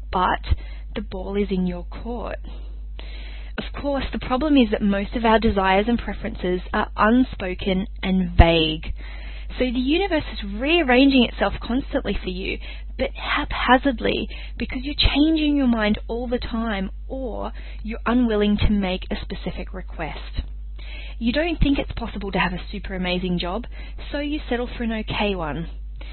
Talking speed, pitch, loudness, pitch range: 155 wpm, 210 Hz, -22 LUFS, 180-245 Hz